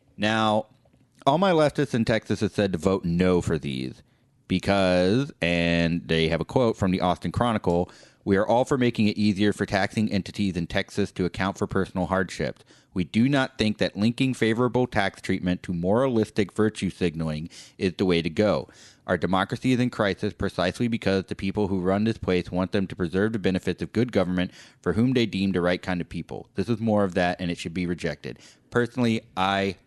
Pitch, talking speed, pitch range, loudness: 95 Hz, 205 wpm, 90-110 Hz, -25 LUFS